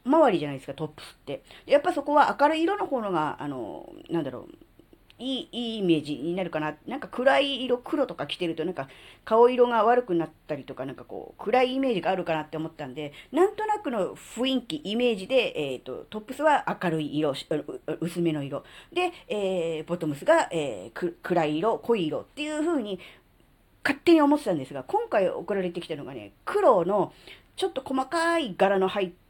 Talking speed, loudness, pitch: 375 characters per minute, -26 LUFS, 215 Hz